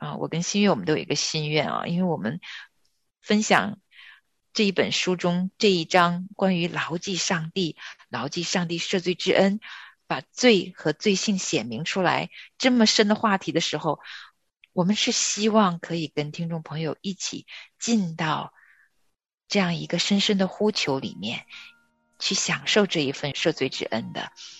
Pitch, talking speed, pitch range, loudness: 180 Hz, 240 characters per minute, 160-200 Hz, -24 LUFS